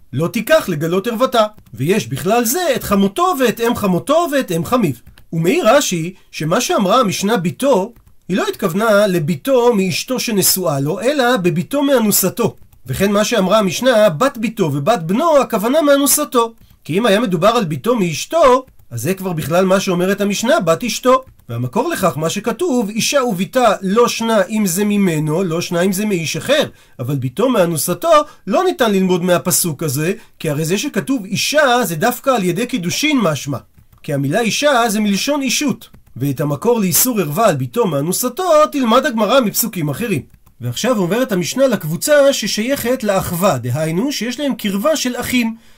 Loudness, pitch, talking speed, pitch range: -15 LUFS, 205 Hz, 160 wpm, 175-245 Hz